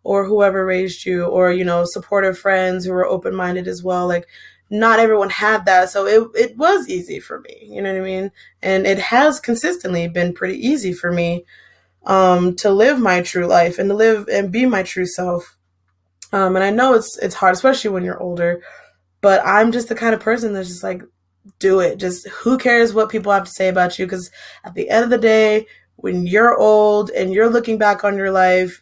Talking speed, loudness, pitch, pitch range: 220 wpm, -16 LUFS, 195 Hz, 180-220 Hz